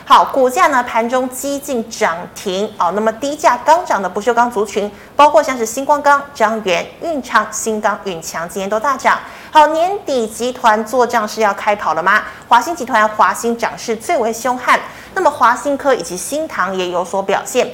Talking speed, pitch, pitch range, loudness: 275 characters per minute, 230 Hz, 210-280 Hz, -15 LUFS